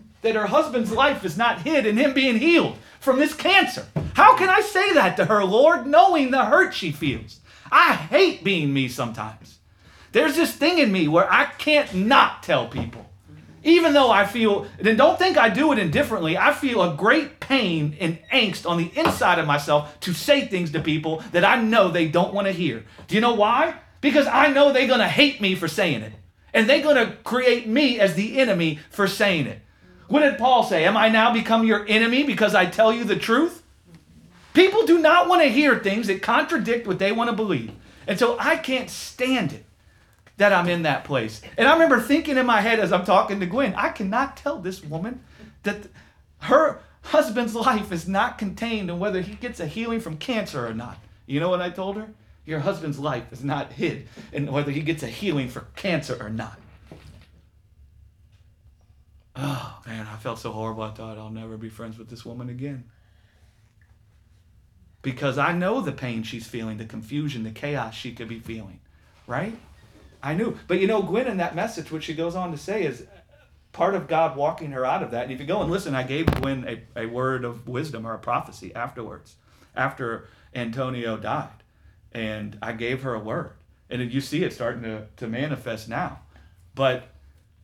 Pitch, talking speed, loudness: 165 Hz, 200 wpm, -21 LUFS